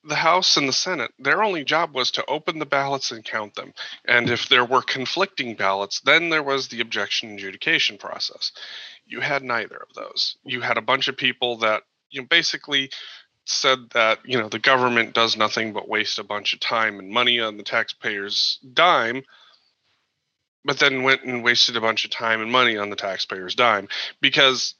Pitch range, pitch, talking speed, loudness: 110-135 Hz, 120 Hz, 195 wpm, -21 LUFS